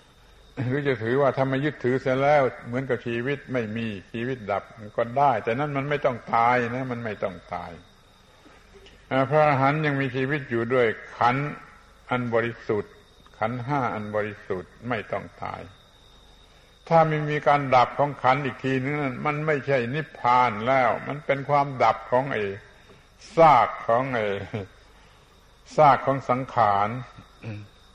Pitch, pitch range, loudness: 130 Hz, 115-140 Hz, -24 LUFS